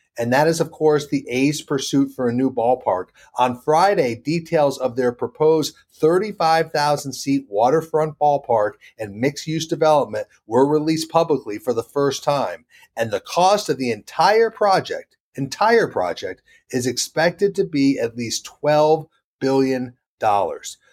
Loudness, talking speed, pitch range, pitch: -20 LUFS, 140 wpm, 130-160 Hz, 145 Hz